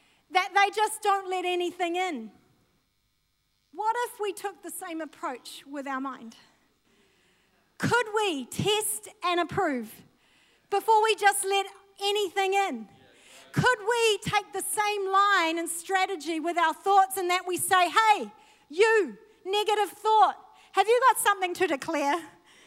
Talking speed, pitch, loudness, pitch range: 140 wpm, 390 Hz, -26 LUFS, 345-415 Hz